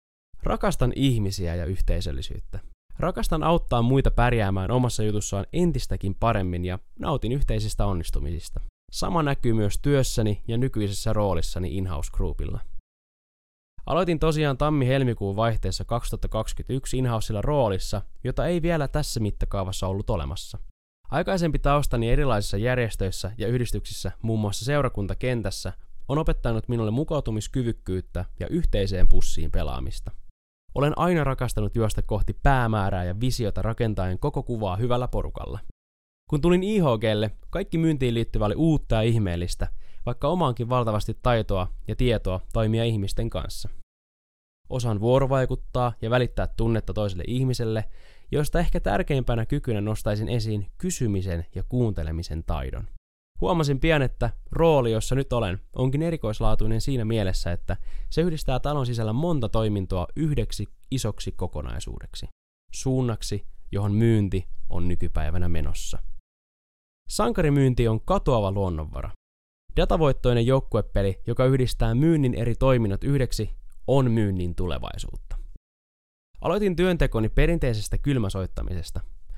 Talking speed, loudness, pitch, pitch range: 115 wpm, -26 LUFS, 110 Hz, 95-130 Hz